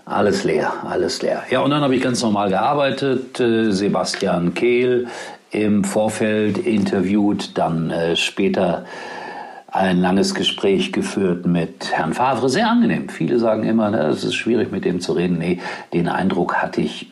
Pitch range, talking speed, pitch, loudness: 95-125 Hz, 155 wpm, 110 Hz, -19 LUFS